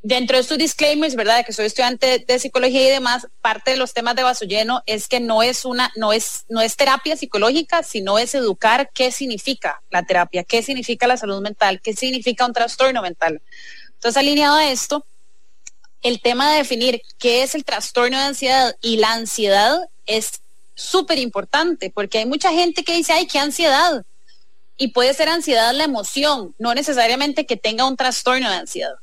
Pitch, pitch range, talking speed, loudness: 250 Hz, 225-285 Hz, 190 wpm, -18 LUFS